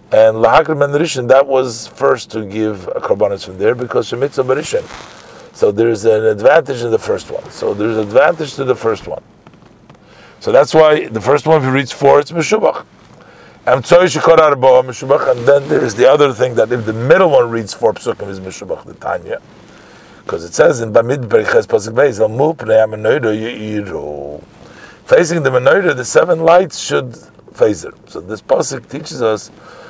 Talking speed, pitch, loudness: 185 wpm, 140 Hz, -13 LUFS